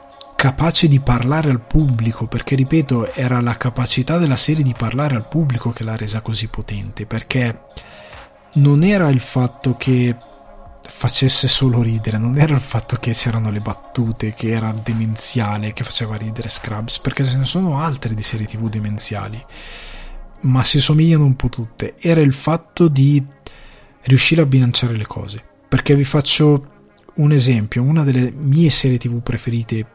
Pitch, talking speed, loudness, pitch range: 125 Hz, 160 wpm, -16 LUFS, 115-140 Hz